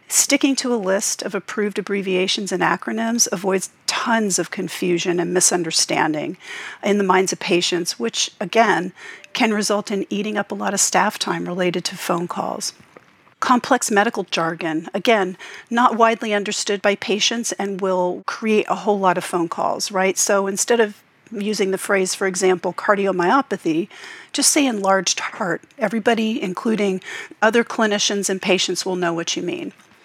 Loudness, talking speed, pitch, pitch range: -19 LUFS, 160 wpm, 200 Hz, 185-225 Hz